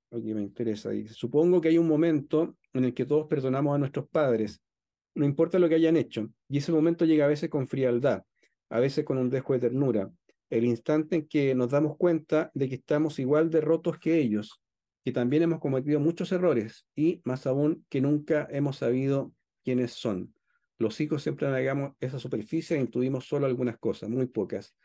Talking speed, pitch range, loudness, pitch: 195 wpm, 125-155 Hz, -28 LUFS, 140 Hz